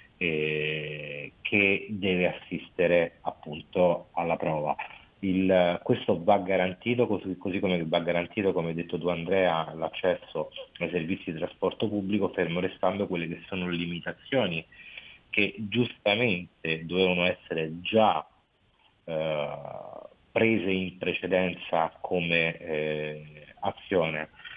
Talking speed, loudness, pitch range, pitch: 110 wpm, -28 LUFS, 80-100 Hz, 90 Hz